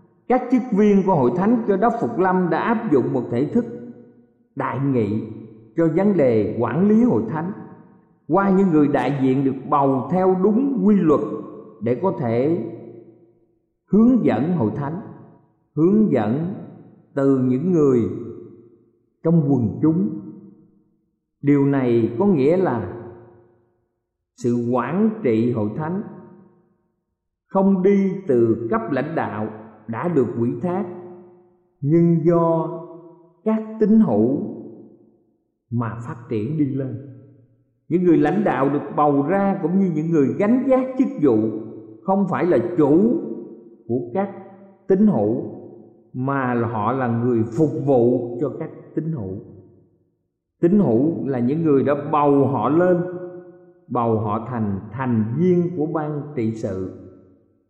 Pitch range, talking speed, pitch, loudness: 120-185 Hz, 135 wpm, 150 Hz, -20 LUFS